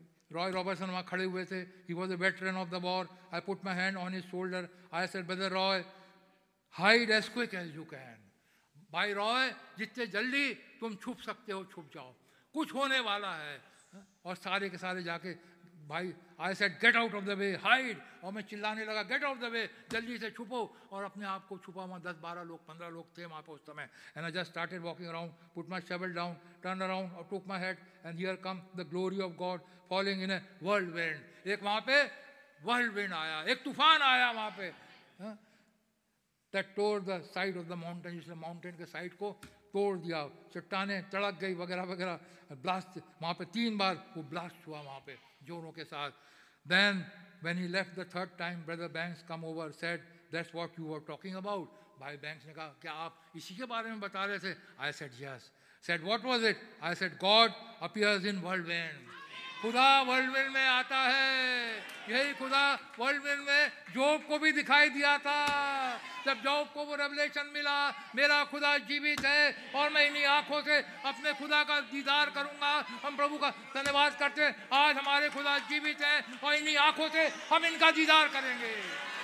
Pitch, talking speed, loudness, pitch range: 195 Hz, 180 wpm, -32 LUFS, 175-260 Hz